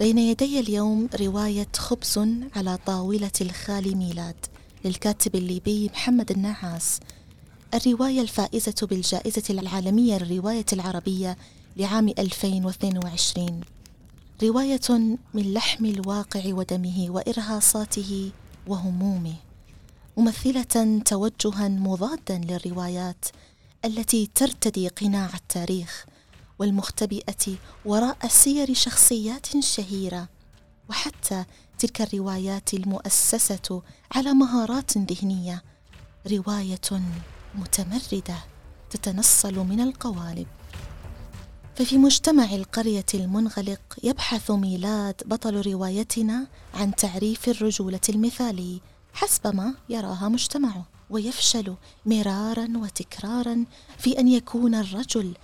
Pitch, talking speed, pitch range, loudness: 205 Hz, 80 wpm, 190-230 Hz, -24 LUFS